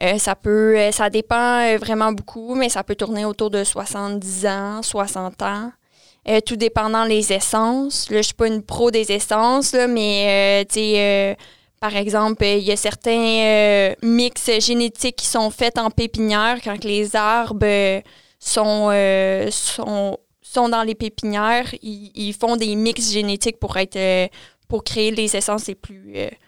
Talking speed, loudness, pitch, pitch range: 175 wpm, -19 LUFS, 215 Hz, 205-230 Hz